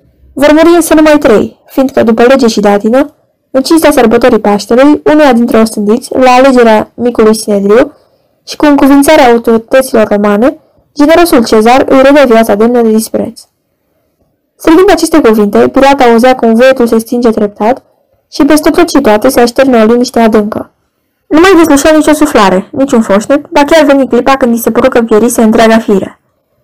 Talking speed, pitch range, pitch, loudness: 160 wpm, 225-290 Hz, 250 Hz, -5 LUFS